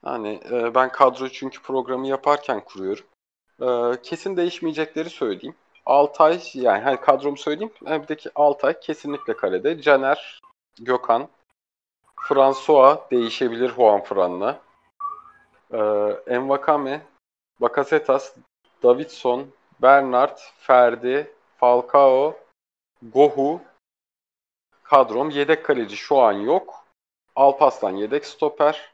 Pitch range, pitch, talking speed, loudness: 125-155 Hz, 140 Hz, 90 wpm, -20 LUFS